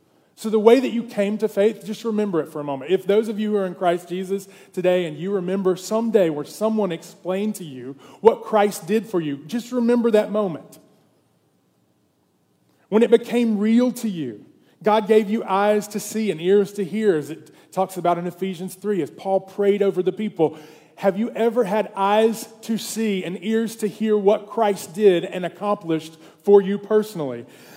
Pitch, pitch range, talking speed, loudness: 200 Hz, 180-215 Hz, 195 wpm, -21 LUFS